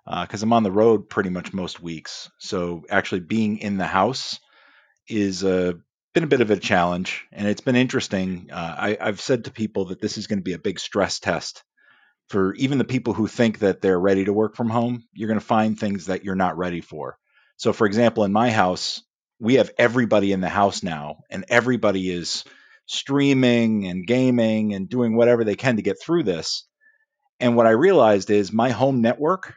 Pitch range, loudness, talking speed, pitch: 95-120 Hz, -21 LUFS, 210 wpm, 110 Hz